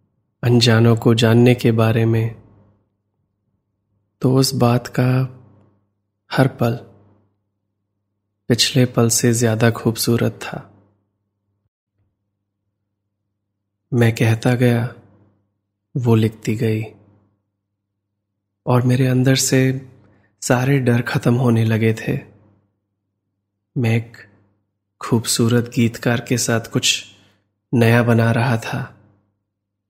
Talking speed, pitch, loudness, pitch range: 90 wpm, 110 Hz, -17 LUFS, 100-120 Hz